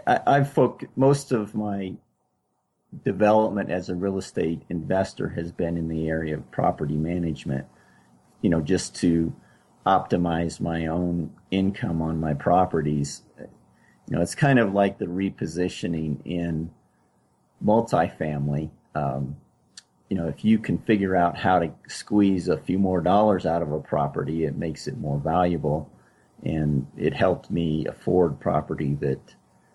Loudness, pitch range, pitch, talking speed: -25 LUFS, 75-95 Hz, 85 Hz, 145 wpm